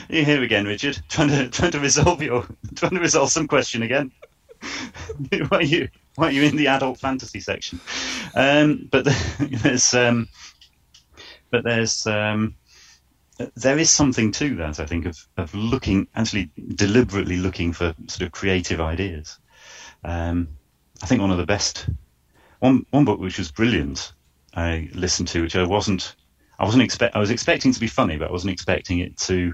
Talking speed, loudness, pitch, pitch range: 185 wpm, -21 LUFS, 105 Hz, 90-135 Hz